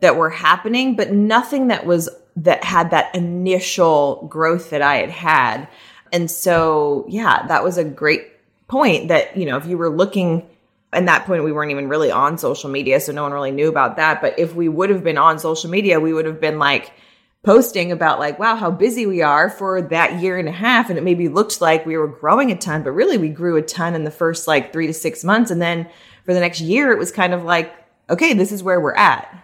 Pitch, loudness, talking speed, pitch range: 170 Hz, -17 LUFS, 240 wpm, 155-185 Hz